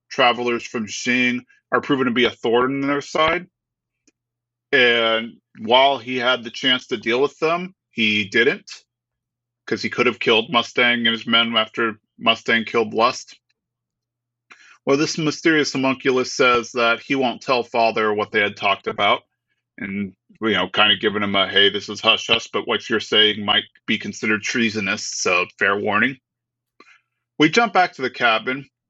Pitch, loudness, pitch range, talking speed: 120 Hz, -19 LUFS, 115-130 Hz, 170 wpm